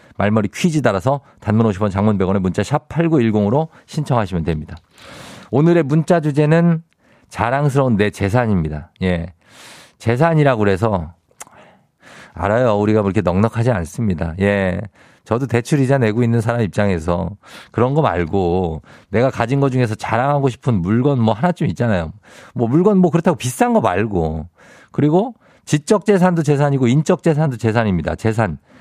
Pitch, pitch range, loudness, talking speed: 115 Hz, 100-145 Hz, -17 LUFS, 325 characters per minute